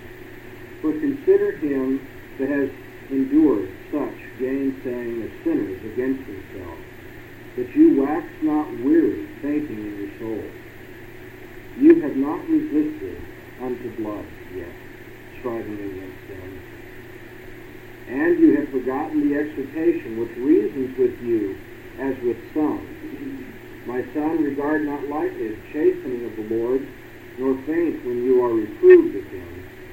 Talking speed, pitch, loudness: 125 wpm, 315 Hz, -22 LUFS